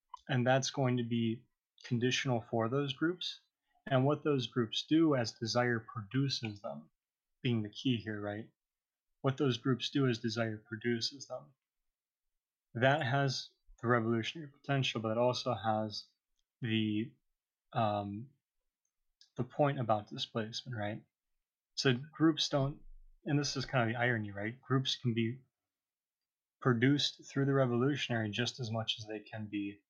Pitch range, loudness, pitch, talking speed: 110-140 Hz, -34 LUFS, 125 Hz, 145 wpm